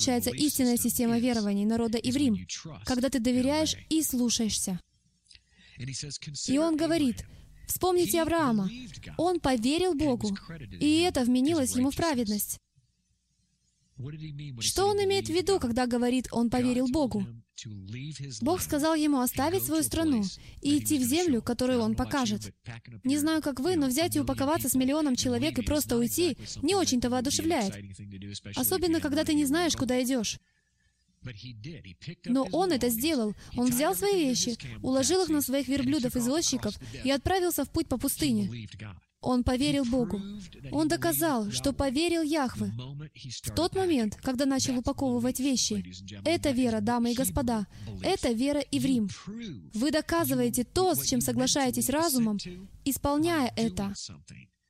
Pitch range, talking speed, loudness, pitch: 215-300 Hz, 140 wpm, -28 LUFS, 255 Hz